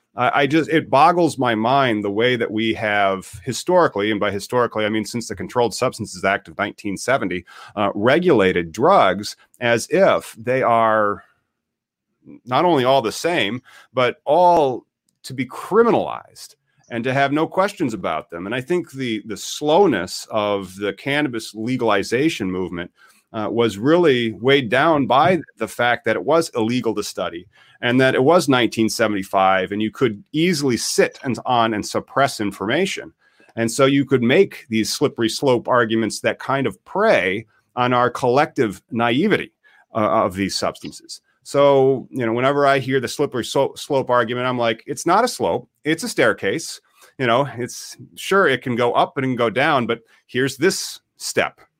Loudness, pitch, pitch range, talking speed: -19 LUFS, 120 Hz, 110-135 Hz, 170 wpm